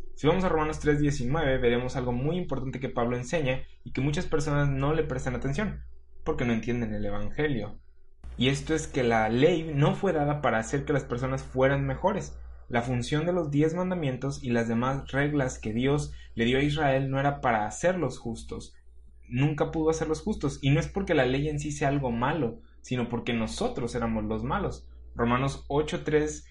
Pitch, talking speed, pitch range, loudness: 135 Hz, 190 wpm, 120-150 Hz, -28 LUFS